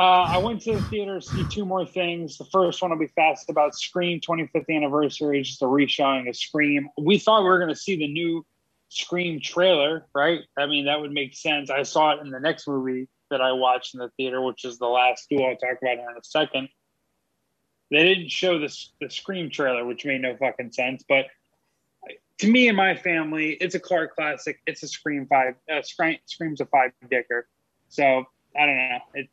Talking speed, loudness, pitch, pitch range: 215 wpm, -23 LUFS, 150 Hz, 130-170 Hz